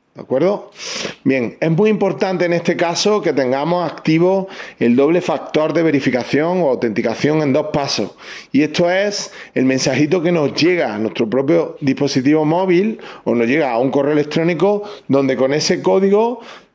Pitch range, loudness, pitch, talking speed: 140-185 Hz, -16 LUFS, 160 Hz, 165 wpm